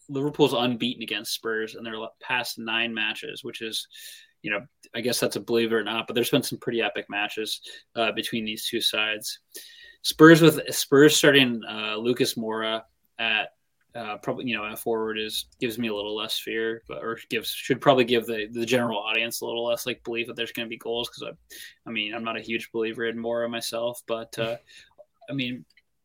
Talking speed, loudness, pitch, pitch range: 205 wpm, -25 LUFS, 115 Hz, 110-125 Hz